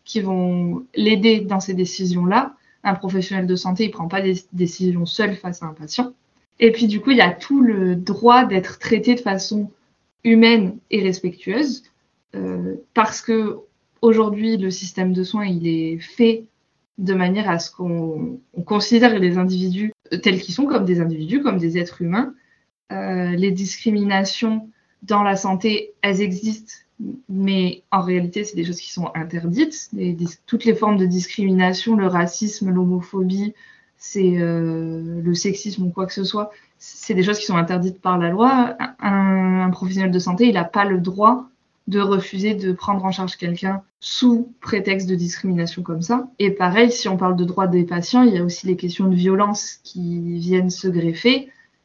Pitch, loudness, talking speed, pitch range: 195 Hz, -19 LUFS, 180 wpm, 180-220 Hz